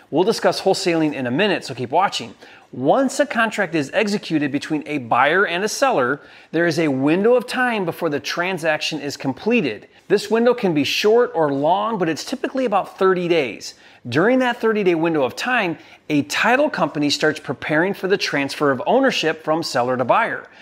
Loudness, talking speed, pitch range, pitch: -19 LUFS, 190 wpm, 150-220 Hz, 170 Hz